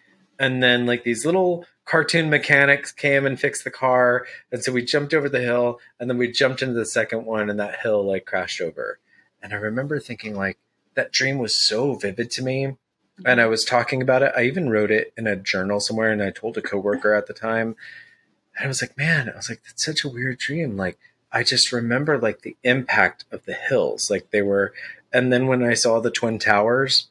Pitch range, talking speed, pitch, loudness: 115-140 Hz, 225 wpm, 125 Hz, -21 LUFS